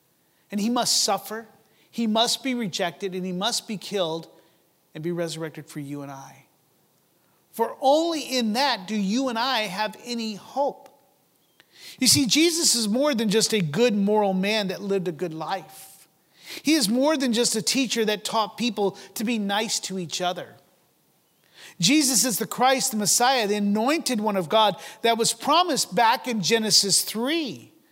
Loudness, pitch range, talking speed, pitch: -23 LUFS, 195-245 Hz, 175 wpm, 215 Hz